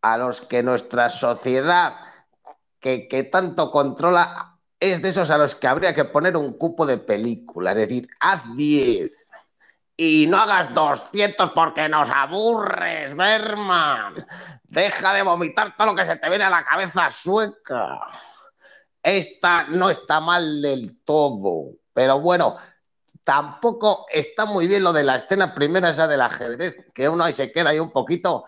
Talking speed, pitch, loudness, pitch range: 160 wpm, 170 Hz, -20 LUFS, 145-190 Hz